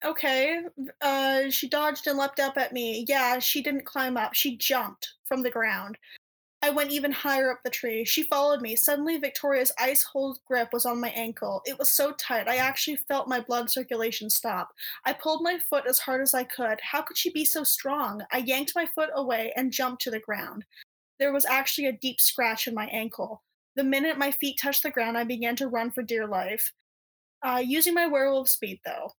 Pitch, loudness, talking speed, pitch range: 265 Hz, -26 LUFS, 210 wpm, 240-285 Hz